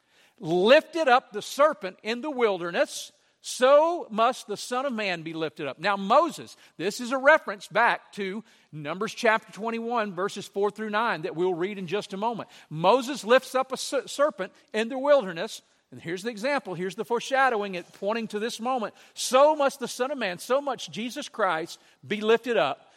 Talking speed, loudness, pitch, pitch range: 185 wpm, -26 LUFS, 225 Hz, 195-260 Hz